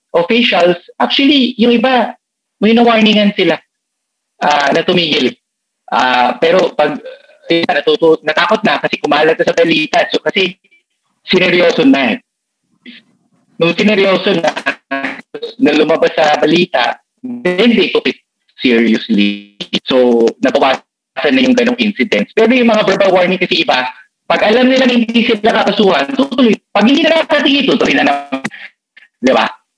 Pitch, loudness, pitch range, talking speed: 205 Hz, -11 LUFS, 165-245 Hz, 135 wpm